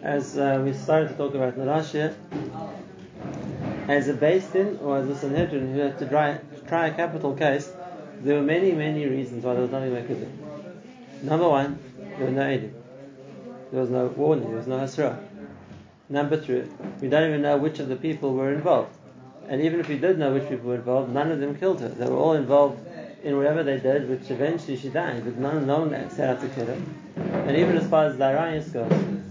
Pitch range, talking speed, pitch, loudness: 135-155 Hz, 220 wpm, 145 Hz, -25 LUFS